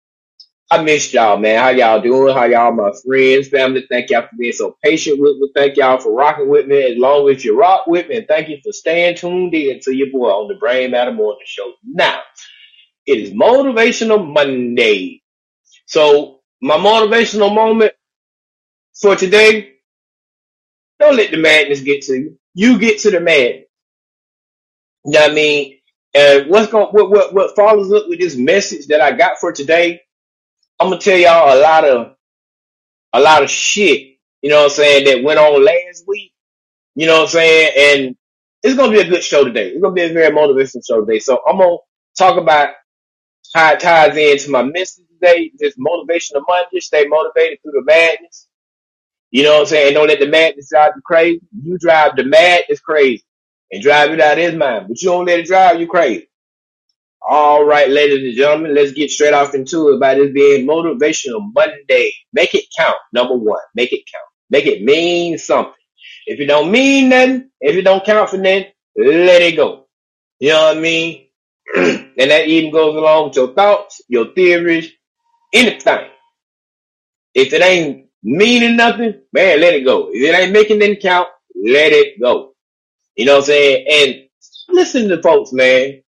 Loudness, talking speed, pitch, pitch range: -11 LUFS, 190 wpm, 170 Hz, 145-220 Hz